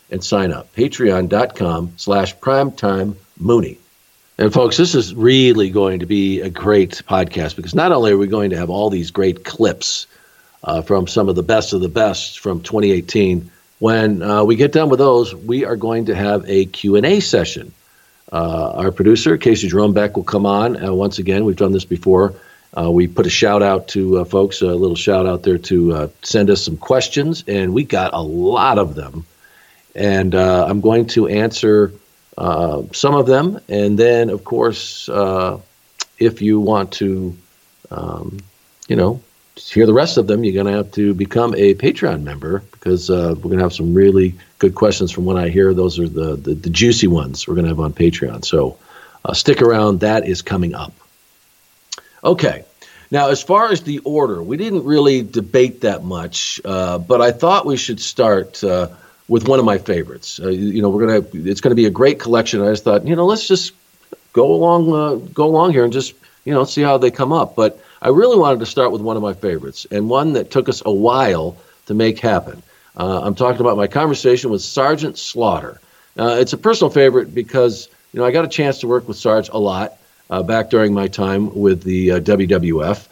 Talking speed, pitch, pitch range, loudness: 205 wpm, 105 Hz, 95-125 Hz, -15 LUFS